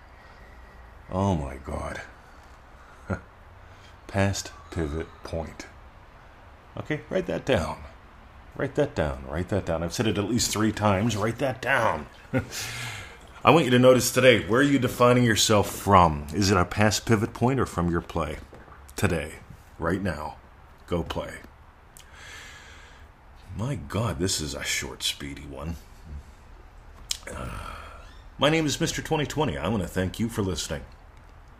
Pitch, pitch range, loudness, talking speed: 95 Hz, 75-115 Hz, -25 LUFS, 140 wpm